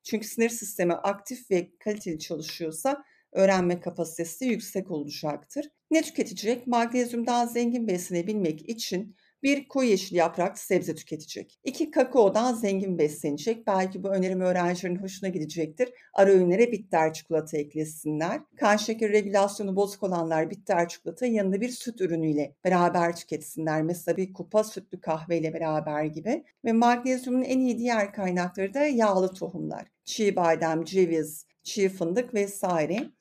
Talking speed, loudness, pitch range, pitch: 135 wpm, -27 LUFS, 165-230 Hz, 190 Hz